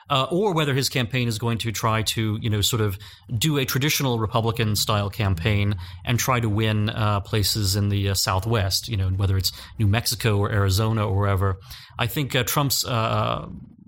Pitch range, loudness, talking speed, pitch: 100-120 Hz, -23 LUFS, 195 wpm, 110 Hz